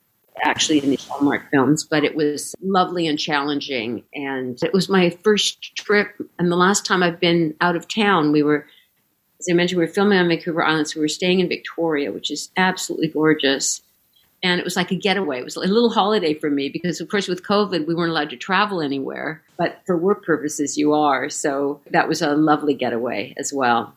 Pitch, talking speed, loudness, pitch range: 160 Hz, 215 wpm, -20 LUFS, 145-180 Hz